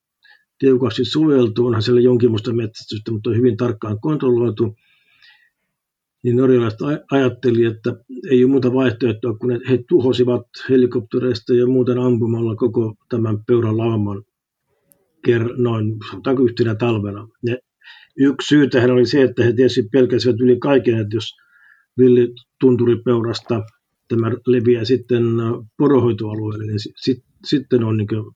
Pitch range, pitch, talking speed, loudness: 115-125 Hz, 120 Hz, 120 wpm, -17 LUFS